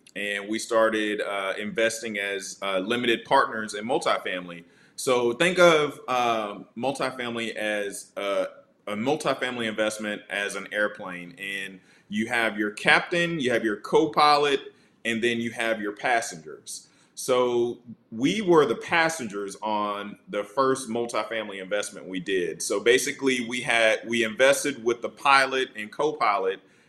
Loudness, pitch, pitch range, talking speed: -25 LUFS, 115 Hz, 105-135 Hz, 140 wpm